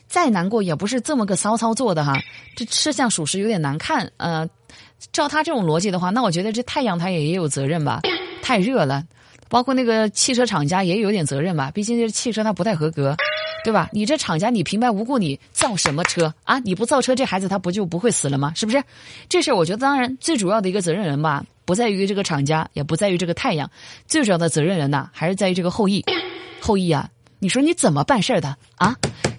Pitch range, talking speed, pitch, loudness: 160-240 Hz, 350 characters per minute, 195 Hz, -20 LUFS